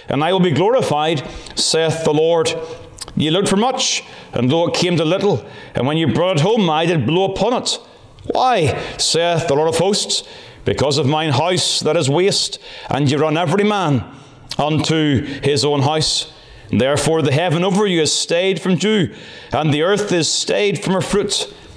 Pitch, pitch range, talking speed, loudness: 160 Hz, 145-185 Hz, 190 wpm, -17 LUFS